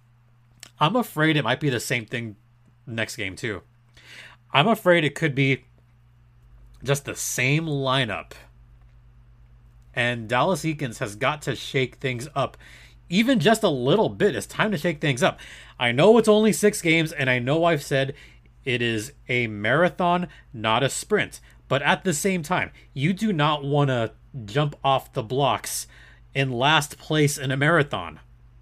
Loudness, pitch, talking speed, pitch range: -23 LUFS, 130 Hz, 165 wpm, 120-155 Hz